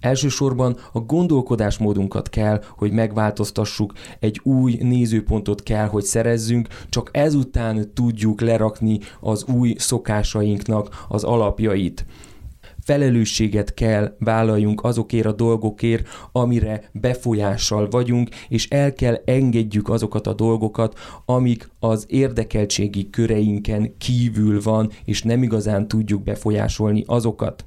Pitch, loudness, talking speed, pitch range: 110 Hz, -20 LUFS, 105 wpm, 105-120 Hz